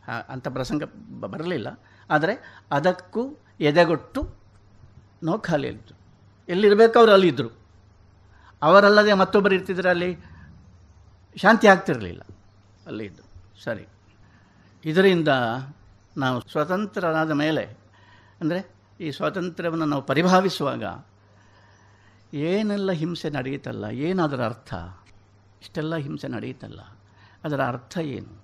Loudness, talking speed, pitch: -22 LUFS, 80 wpm, 125 Hz